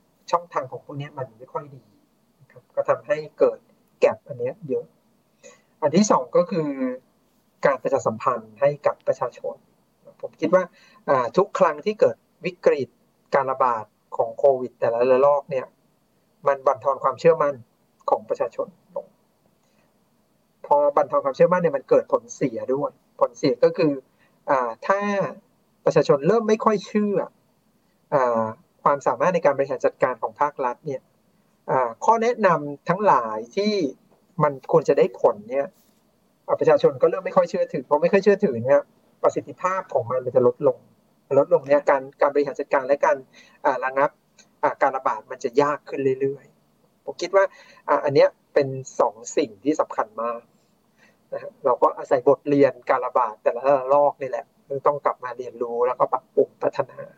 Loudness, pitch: -22 LUFS, 215 Hz